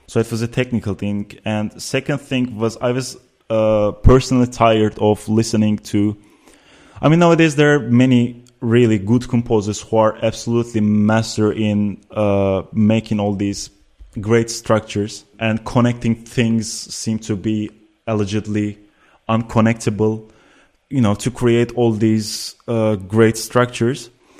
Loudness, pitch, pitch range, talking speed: -18 LUFS, 110 Hz, 105-120 Hz, 135 wpm